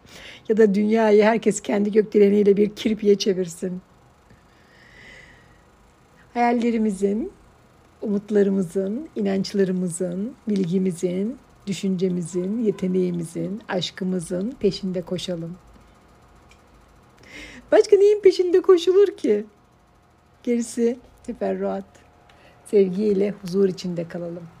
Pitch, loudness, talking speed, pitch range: 200 Hz, -21 LUFS, 70 wpm, 185-220 Hz